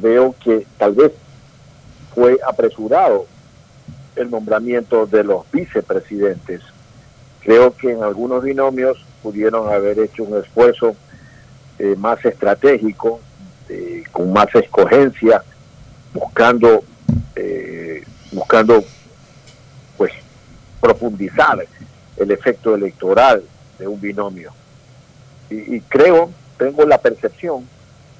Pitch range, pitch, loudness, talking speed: 115-170 Hz, 130 Hz, -15 LUFS, 95 wpm